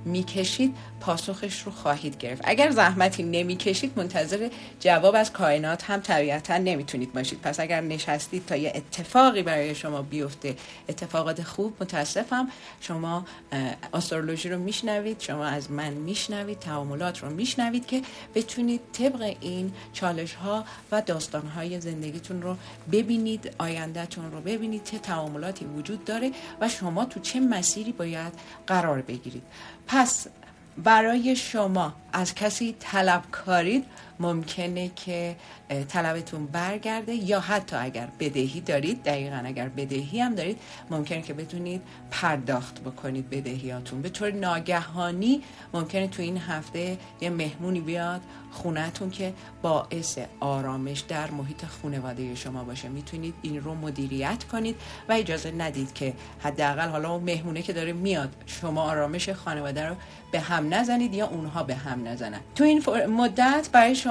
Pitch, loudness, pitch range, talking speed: 170 Hz, -28 LUFS, 150-200 Hz, 135 wpm